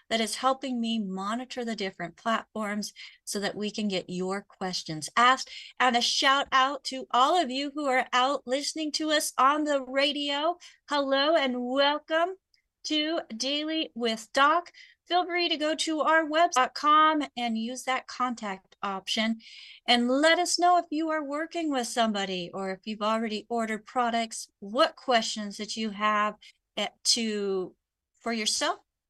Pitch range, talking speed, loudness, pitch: 220-300 Hz, 155 wpm, -27 LUFS, 255 Hz